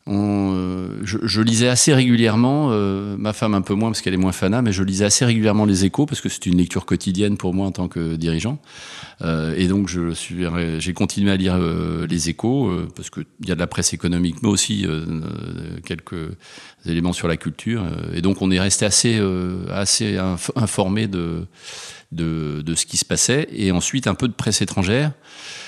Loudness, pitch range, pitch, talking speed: -20 LUFS, 90-110 Hz, 95 Hz, 205 wpm